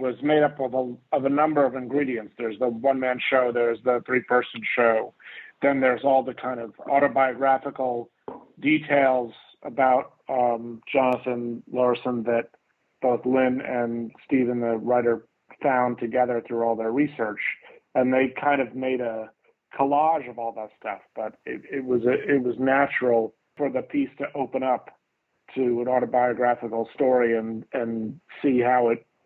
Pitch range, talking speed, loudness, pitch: 120-135 Hz, 160 wpm, -24 LUFS, 125 Hz